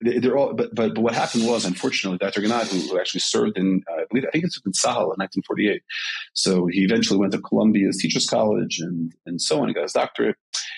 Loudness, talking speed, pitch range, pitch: -22 LUFS, 225 wpm, 90-115 Hz, 95 Hz